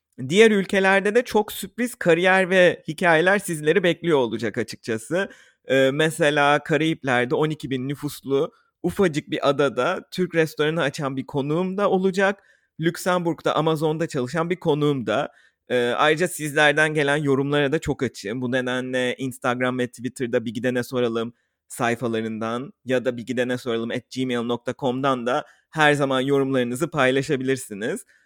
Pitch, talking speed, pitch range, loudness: 145 Hz, 135 wpm, 125-165 Hz, -22 LUFS